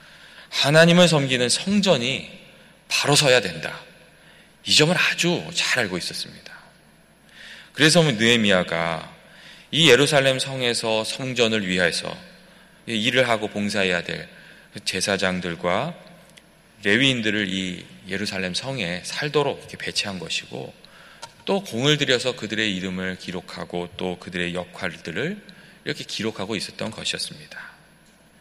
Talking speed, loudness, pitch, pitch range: 275 characters per minute, -21 LUFS, 115 Hz, 95-155 Hz